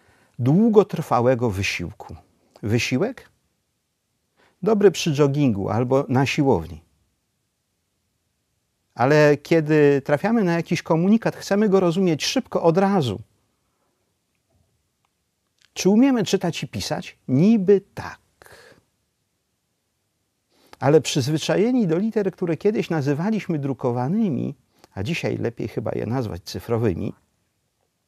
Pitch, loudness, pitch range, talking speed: 150 Hz, -21 LUFS, 120-190 Hz, 90 wpm